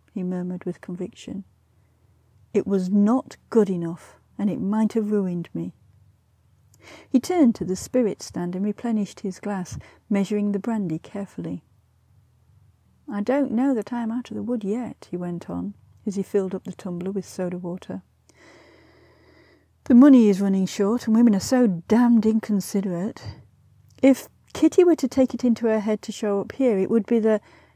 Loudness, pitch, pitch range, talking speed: -23 LUFS, 200 Hz, 175-230 Hz, 175 wpm